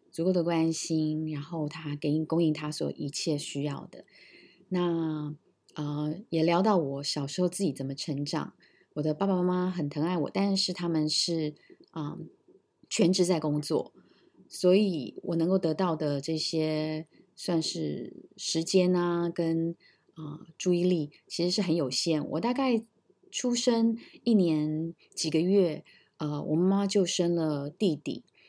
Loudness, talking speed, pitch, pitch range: -29 LUFS, 215 characters per minute, 165 Hz, 155-180 Hz